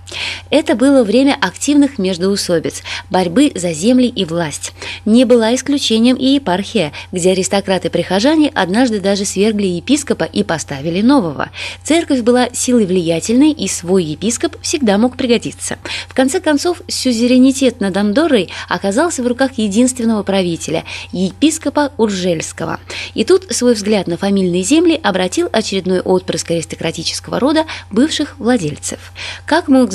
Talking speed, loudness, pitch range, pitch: 125 wpm, -14 LUFS, 185-265 Hz, 220 Hz